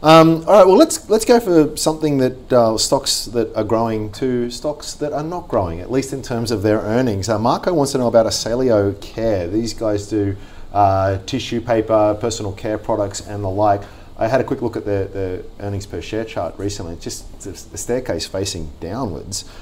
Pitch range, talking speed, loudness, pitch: 100-130 Hz, 210 wpm, -18 LUFS, 110 Hz